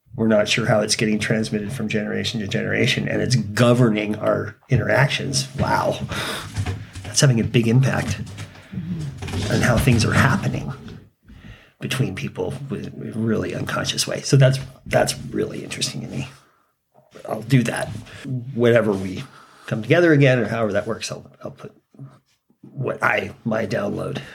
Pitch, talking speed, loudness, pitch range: 110 Hz, 150 wpm, -21 LUFS, 105-125 Hz